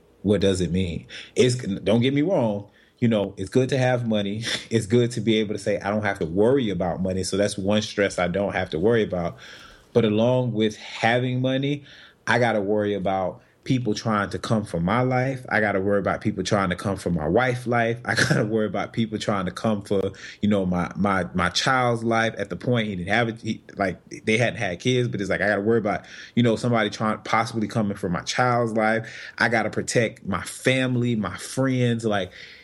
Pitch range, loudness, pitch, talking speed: 100-120 Hz, -23 LUFS, 110 Hz, 225 wpm